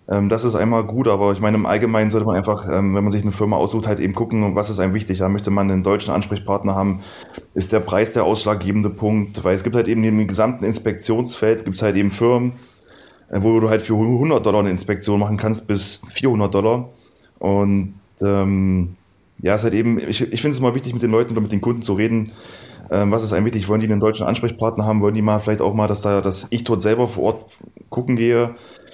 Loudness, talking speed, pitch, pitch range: -19 LUFS, 230 wpm, 105 Hz, 100-115 Hz